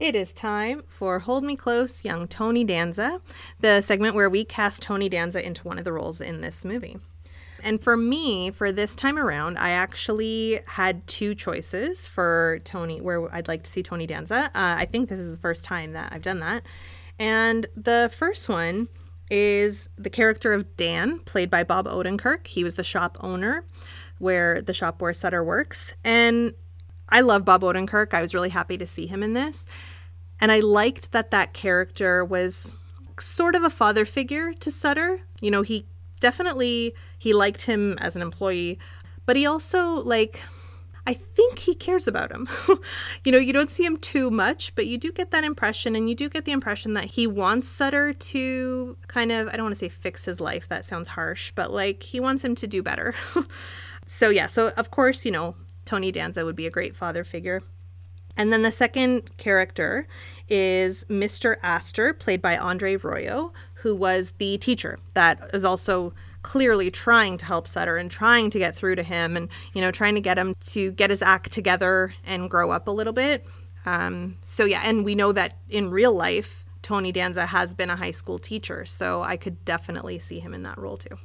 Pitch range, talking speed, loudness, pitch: 165-230 Hz, 200 wpm, -23 LUFS, 190 Hz